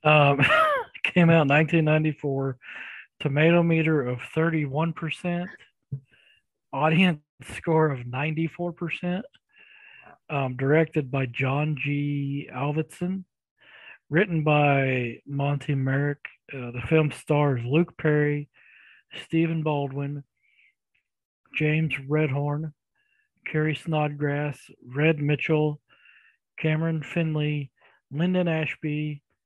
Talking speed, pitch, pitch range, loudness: 85 wpm, 150 Hz, 145-165 Hz, -25 LUFS